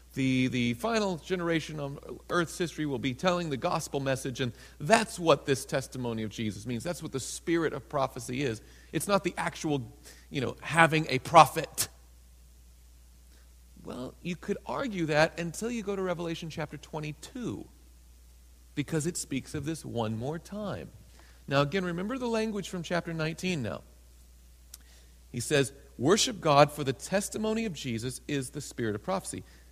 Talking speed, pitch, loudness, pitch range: 160 wpm, 145 Hz, -30 LUFS, 110-170 Hz